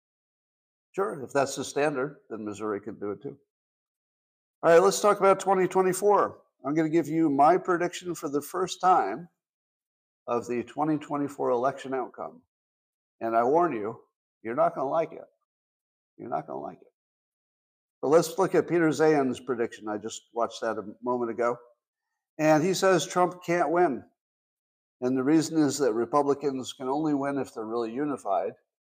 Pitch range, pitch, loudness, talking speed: 120-170 Hz, 145 Hz, -27 LUFS, 170 wpm